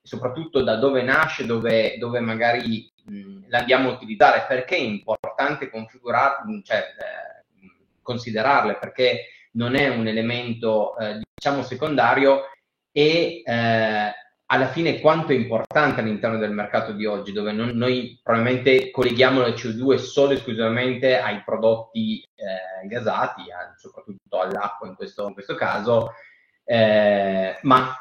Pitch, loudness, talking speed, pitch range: 125 Hz, -21 LUFS, 130 wpm, 110-140 Hz